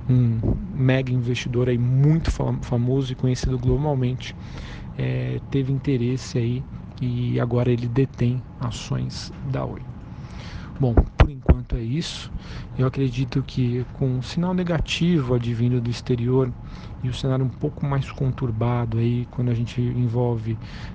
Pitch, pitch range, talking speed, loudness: 125 Hz, 120-135 Hz, 130 wpm, -24 LUFS